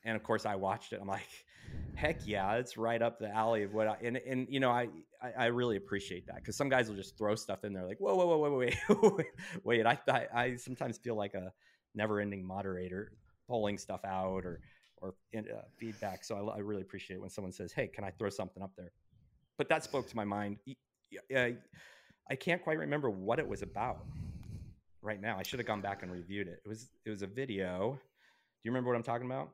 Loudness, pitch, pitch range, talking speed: -36 LUFS, 110 Hz, 100-125 Hz, 235 wpm